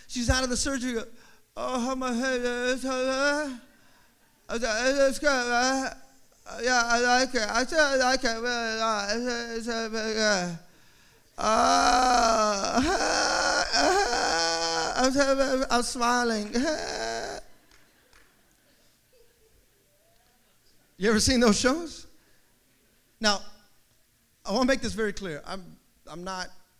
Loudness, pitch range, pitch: -25 LUFS, 220-260 Hz, 240 Hz